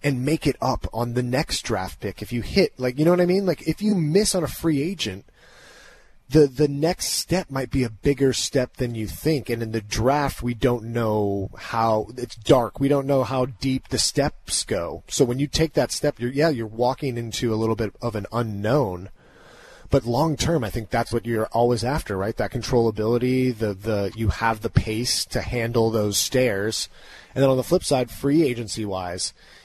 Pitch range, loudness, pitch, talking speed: 110-140 Hz, -23 LUFS, 120 Hz, 215 wpm